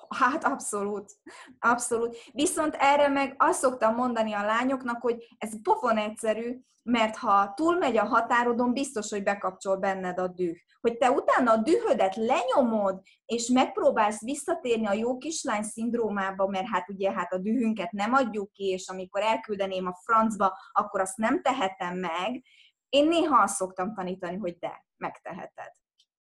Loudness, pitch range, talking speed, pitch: -27 LUFS, 200-265 Hz, 150 wpm, 225 Hz